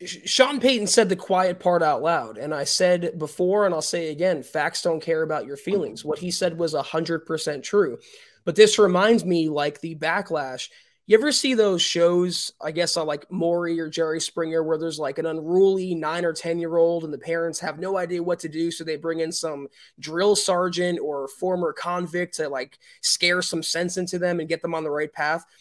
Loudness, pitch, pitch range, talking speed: -23 LUFS, 170 Hz, 160-185 Hz, 215 wpm